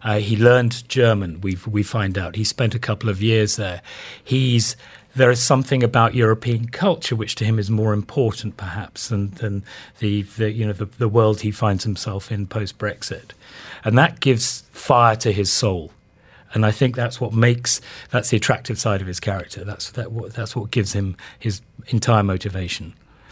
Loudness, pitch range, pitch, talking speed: -20 LUFS, 105-120 Hz, 110 Hz, 190 wpm